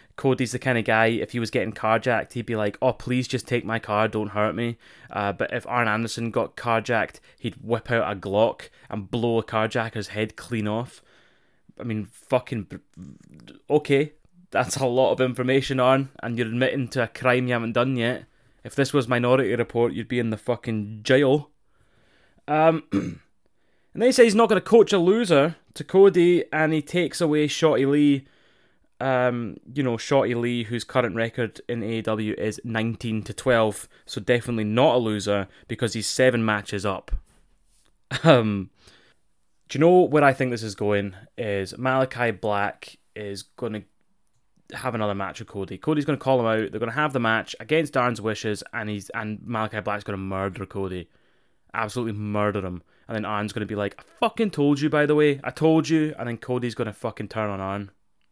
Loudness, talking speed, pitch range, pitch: -24 LUFS, 190 wpm, 105-130 Hz, 120 Hz